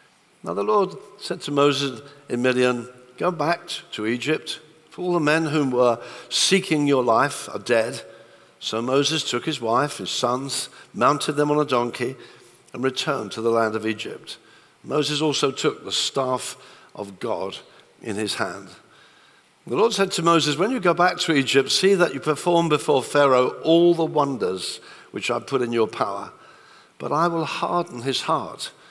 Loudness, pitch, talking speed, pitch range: -22 LUFS, 145 Hz, 175 wpm, 125-170 Hz